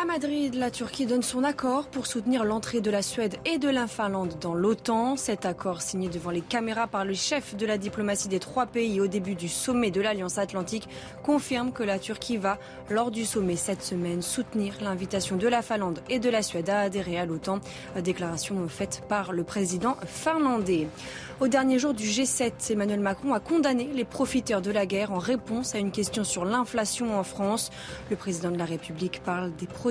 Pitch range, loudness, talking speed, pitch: 190-245 Hz, -28 LUFS, 205 wpm, 210 Hz